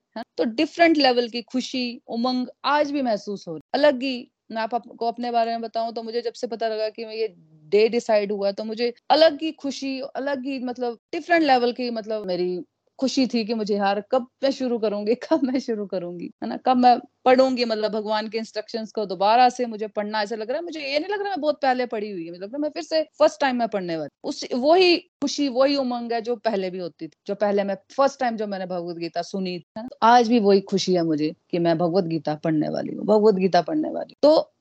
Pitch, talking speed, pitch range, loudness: 235 Hz, 230 wpm, 205-270 Hz, -23 LUFS